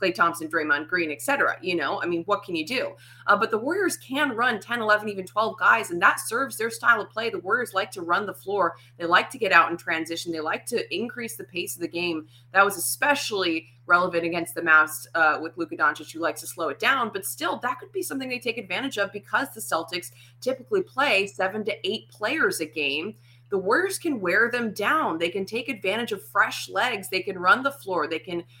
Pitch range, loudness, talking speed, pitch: 165-245 Hz, -25 LUFS, 235 wpm, 195 Hz